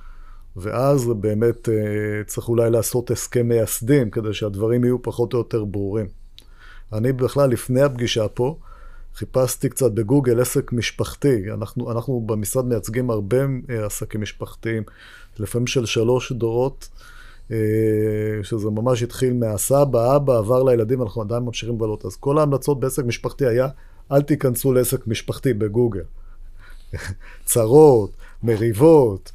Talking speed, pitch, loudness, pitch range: 120 wpm, 115 Hz, -20 LUFS, 110-130 Hz